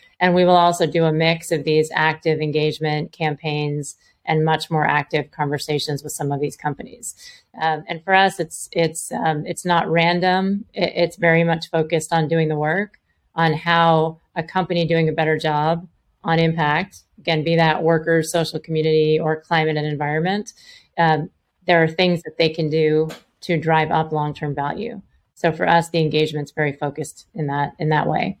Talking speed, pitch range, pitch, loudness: 180 wpm, 155-170 Hz, 160 Hz, -20 LUFS